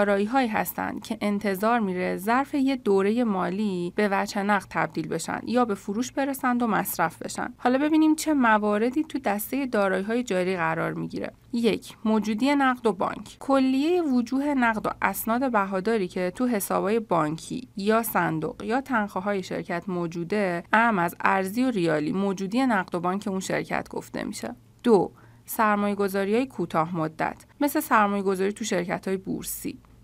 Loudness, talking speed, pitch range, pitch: -25 LUFS, 160 wpm, 190-245 Hz, 210 Hz